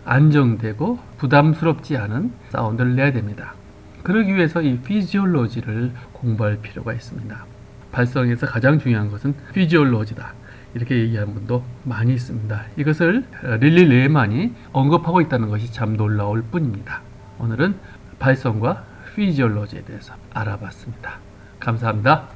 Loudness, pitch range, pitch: -20 LUFS, 110-145 Hz, 125 Hz